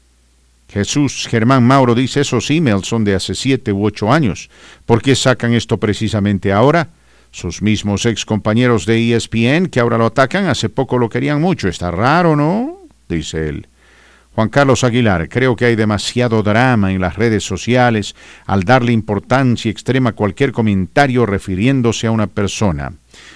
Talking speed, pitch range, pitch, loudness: 160 wpm, 100-130 Hz, 115 Hz, -14 LUFS